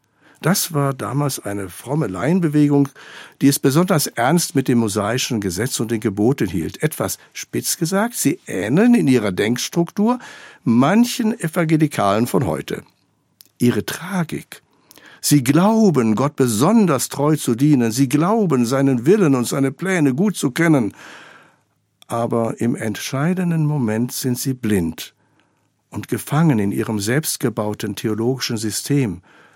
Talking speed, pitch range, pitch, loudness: 130 wpm, 120-165 Hz, 140 Hz, -18 LUFS